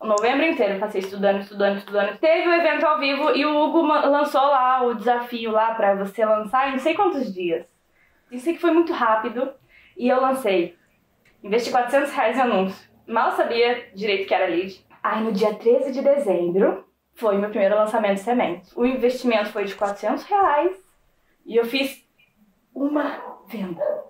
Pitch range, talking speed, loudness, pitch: 205-280 Hz, 175 wpm, -21 LUFS, 240 Hz